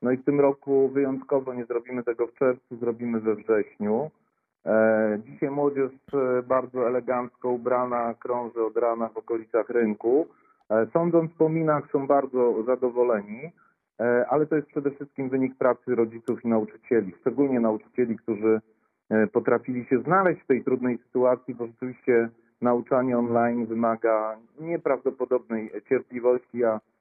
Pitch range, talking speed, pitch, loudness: 115-135 Hz, 130 wpm, 125 Hz, -25 LUFS